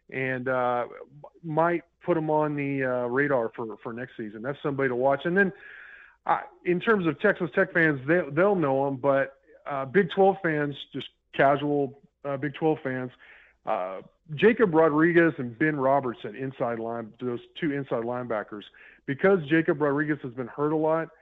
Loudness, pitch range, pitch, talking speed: -26 LUFS, 130-165 Hz, 145 Hz, 175 wpm